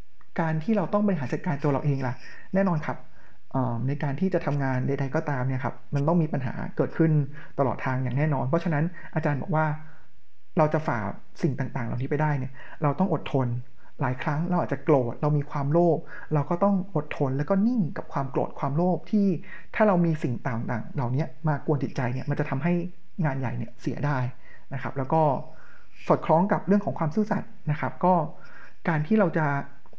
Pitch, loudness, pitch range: 150 Hz, -27 LUFS, 135-170 Hz